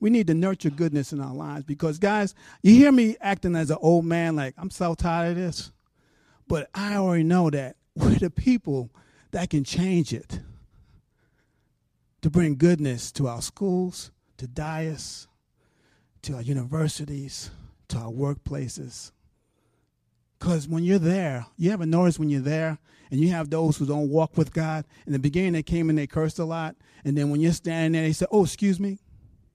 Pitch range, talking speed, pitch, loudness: 140-175 Hz, 185 wpm, 160 Hz, -24 LUFS